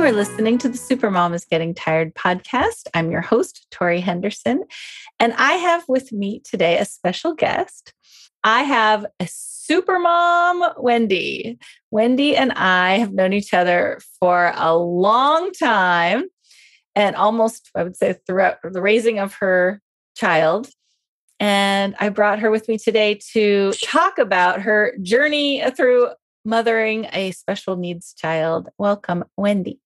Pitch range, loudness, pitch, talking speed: 185-250 Hz, -18 LUFS, 210 Hz, 145 wpm